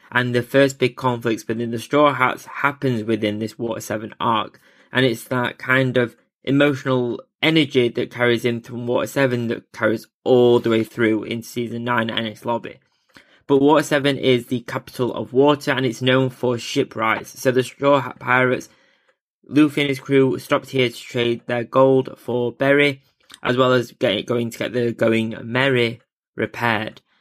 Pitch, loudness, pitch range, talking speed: 125 Hz, -20 LUFS, 115-135 Hz, 180 wpm